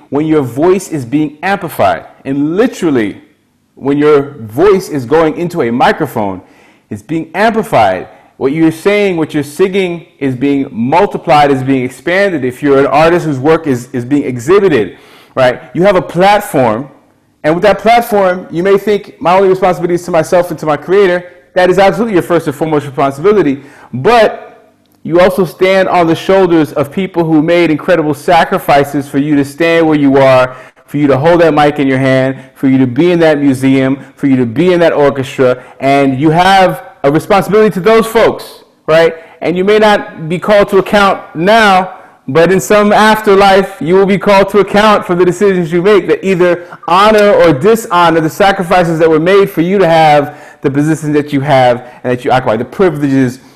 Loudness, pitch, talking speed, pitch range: -10 LUFS, 165 Hz, 195 wpm, 140-190 Hz